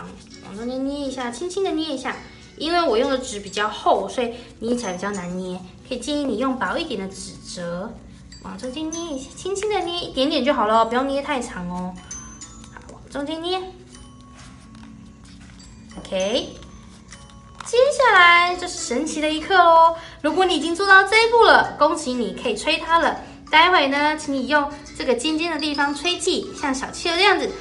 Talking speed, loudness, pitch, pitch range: 265 characters per minute, -20 LUFS, 295 Hz, 250-345 Hz